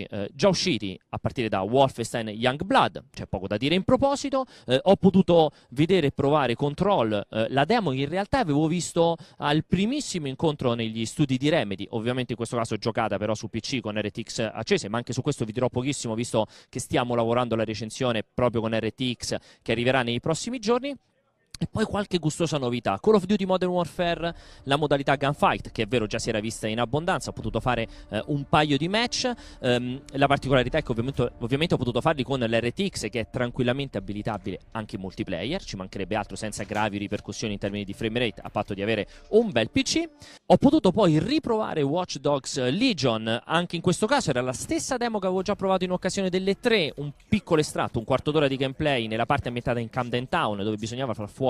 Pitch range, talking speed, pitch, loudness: 115-170 Hz, 205 wpm, 130 Hz, -26 LUFS